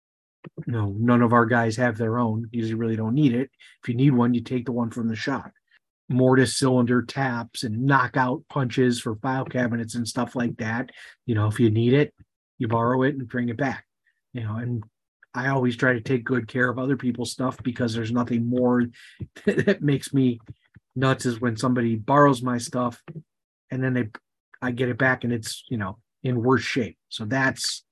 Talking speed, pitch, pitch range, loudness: 205 wpm, 125 Hz, 120-130 Hz, -24 LUFS